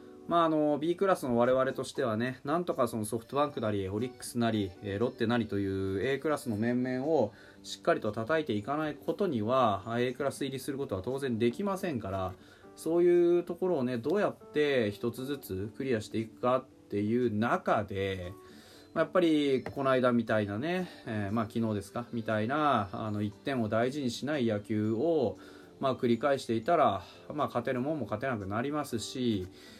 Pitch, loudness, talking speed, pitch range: 120 Hz, -31 LUFS, 370 characters per minute, 105-140 Hz